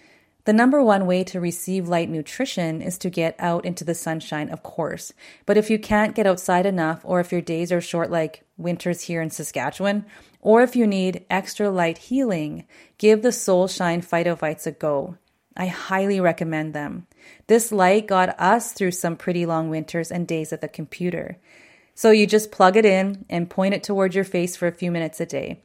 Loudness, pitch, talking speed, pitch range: -22 LUFS, 180 Hz, 200 wpm, 165-200 Hz